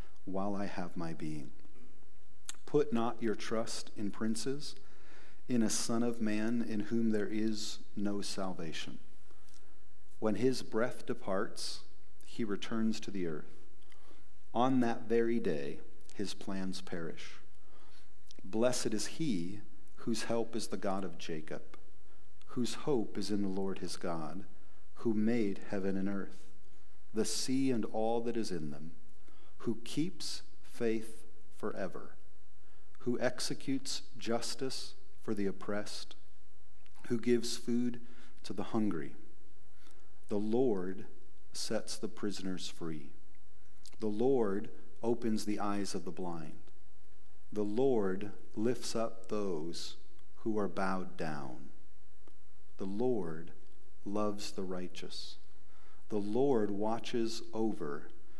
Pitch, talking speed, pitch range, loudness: 105 Hz, 120 wpm, 95-115 Hz, -37 LUFS